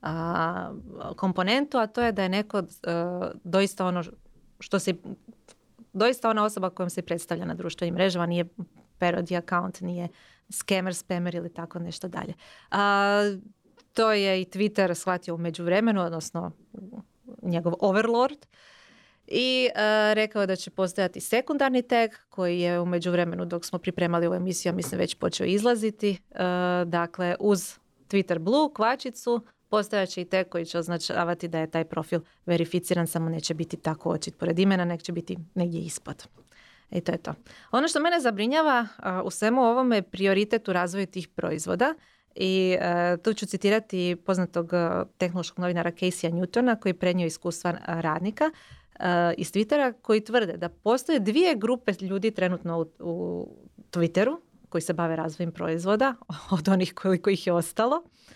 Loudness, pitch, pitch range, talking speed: -27 LUFS, 185 Hz, 175-215 Hz, 155 wpm